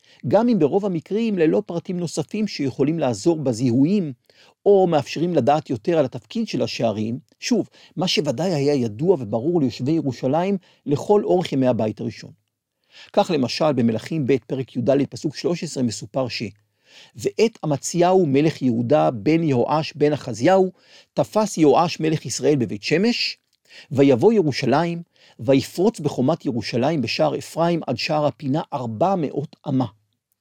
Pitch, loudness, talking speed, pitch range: 145 Hz, -21 LUFS, 135 wpm, 130-170 Hz